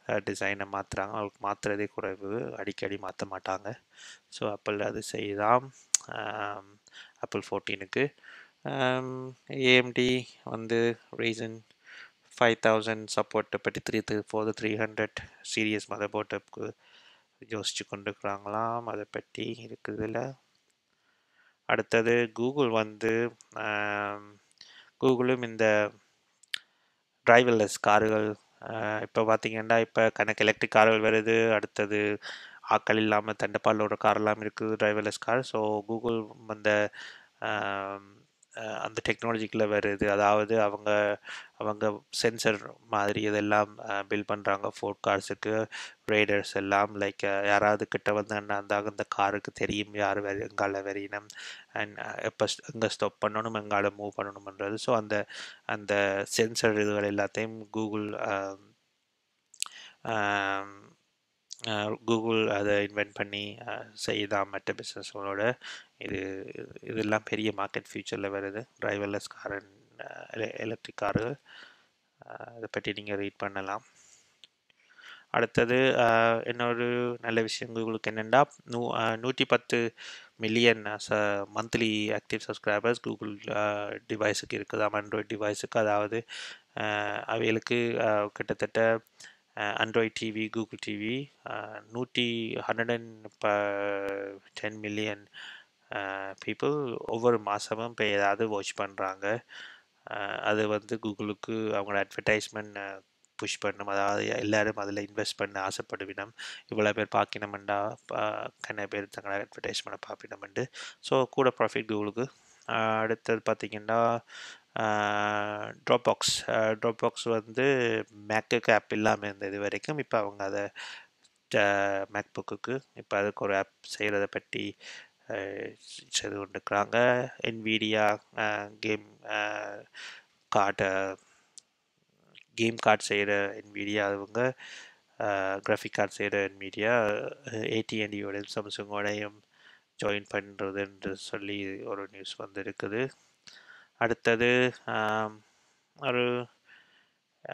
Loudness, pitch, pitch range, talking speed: -30 LUFS, 105 Hz, 100-115 Hz, 95 wpm